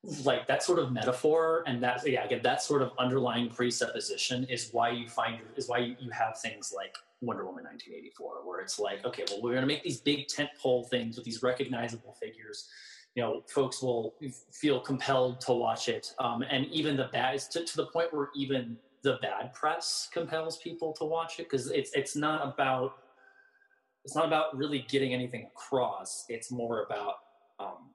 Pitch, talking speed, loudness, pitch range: 135 Hz, 195 wpm, -32 LUFS, 125-155 Hz